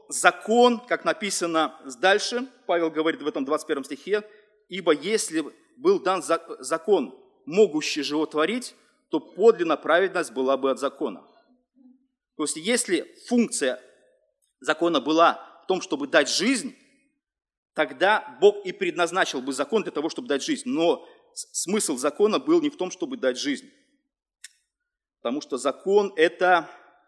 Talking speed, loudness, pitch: 135 wpm, -24 LUFS, 210 Hz